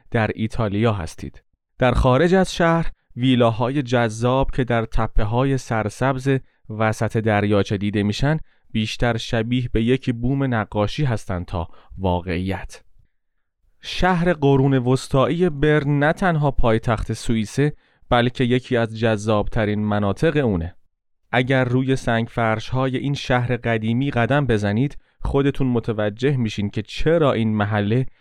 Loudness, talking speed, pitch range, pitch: -21 LUFS, 125 wpm, 110-135 Hz, 120 Hz